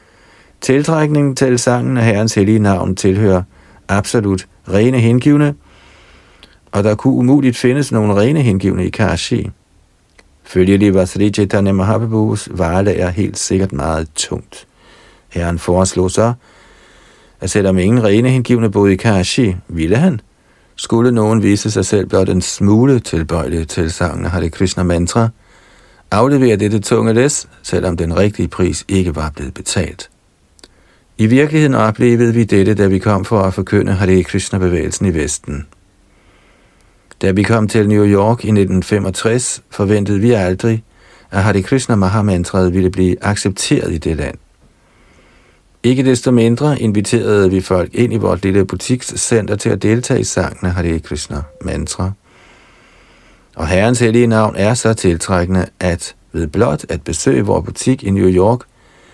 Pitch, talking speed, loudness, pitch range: 100 Hz, 145 wpm, -14 LUFS, 90-115 Hz